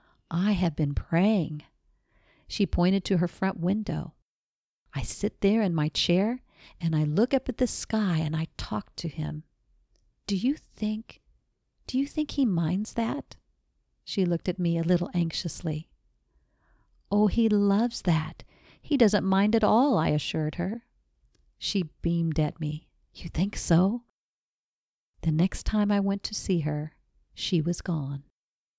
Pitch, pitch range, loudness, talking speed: 175 Hz, 155-210 Hz, -27 LUFS, 155 wpm